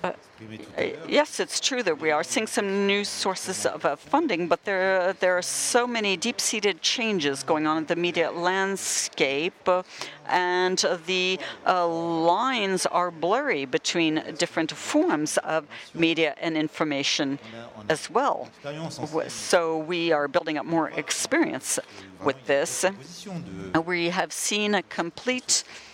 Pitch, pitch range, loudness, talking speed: 175 Hz, 160-195 Hz, -25 LUFS, 140 wpm